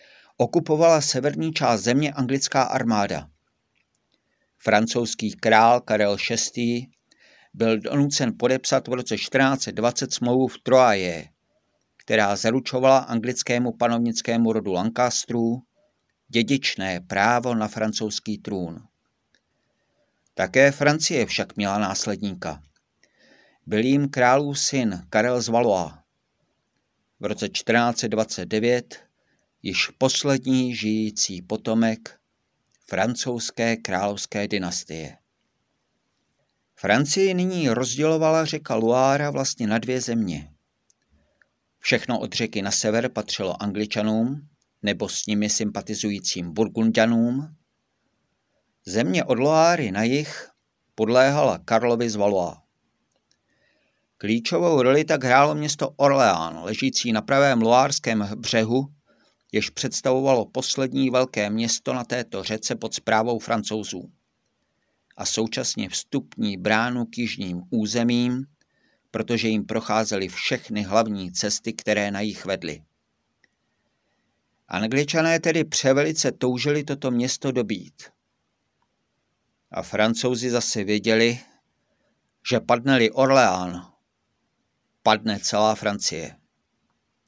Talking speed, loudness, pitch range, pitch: 95 wpm, -22 LUFS, 105-130 Hz, 115 Hz